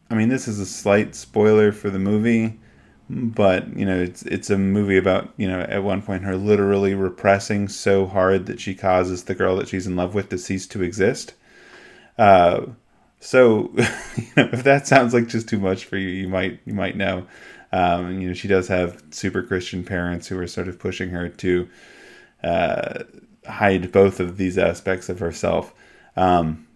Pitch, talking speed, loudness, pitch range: 95 Hz, 190 wpm, -20 LUFS, 90-105 Hz